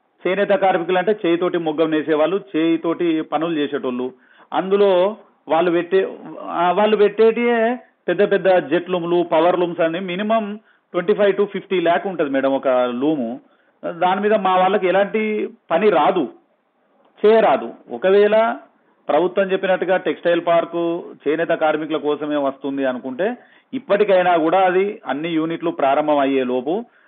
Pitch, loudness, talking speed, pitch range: 180 Hz, -18 LUFS, 125 wpm, 160-200 Hz